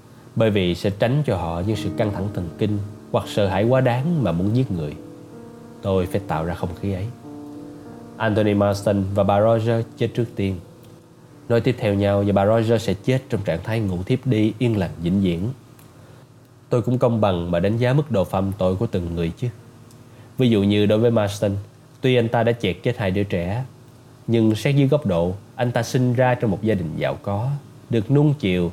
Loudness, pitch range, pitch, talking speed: -21 LUFS, 100-125 Hz, 115 Hz, 215 wpm